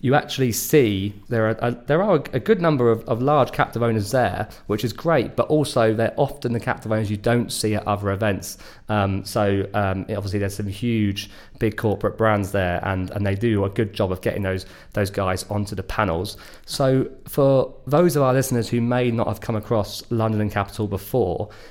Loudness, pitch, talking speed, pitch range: -22 LUFS, 110 Hz, 215 wpm, 100-120 Hz